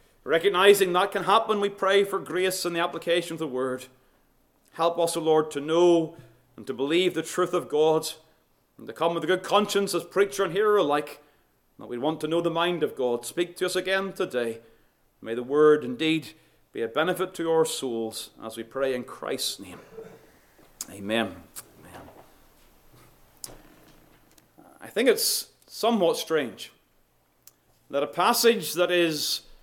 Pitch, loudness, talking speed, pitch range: 165 Hz, -25 LUFS, 165 wpm, 135-185 Hz